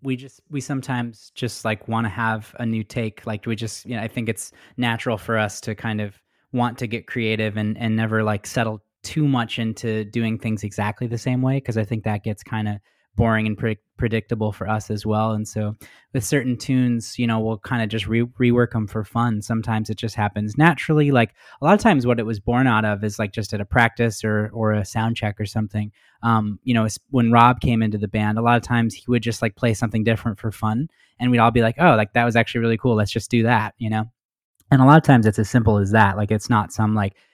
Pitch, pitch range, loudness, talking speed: 115 Hz, 110-120 Hz, -21 LUFS, 255 wpm